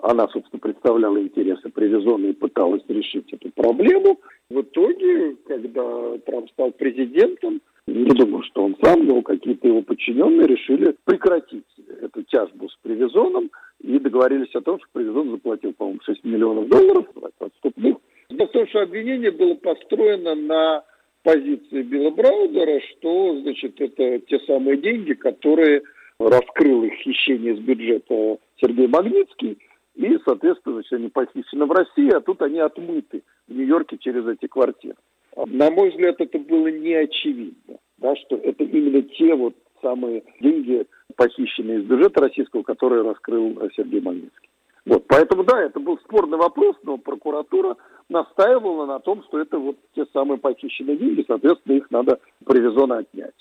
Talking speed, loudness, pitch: 145 wpm, -20 LUFS, 315 Hz